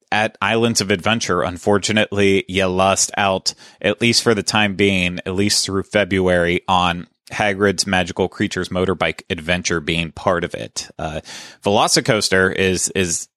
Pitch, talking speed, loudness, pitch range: 95 Hz, 145 wpm, -18 LUFS, 90-105 Hz